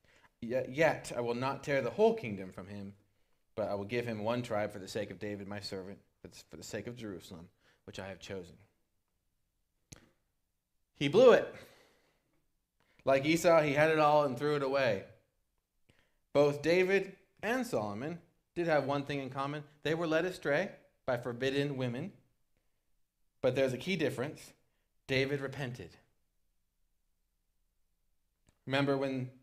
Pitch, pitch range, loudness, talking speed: 130 Hz, 100-150 Hz, -32 LUFS, 150 wpm